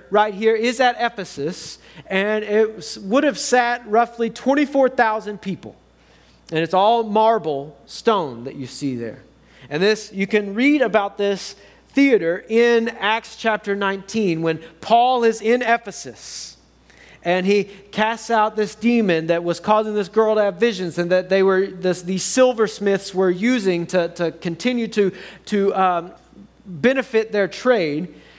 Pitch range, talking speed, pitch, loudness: 180-230 Hz, 150 wpm, 205 Hz, -19 LUFS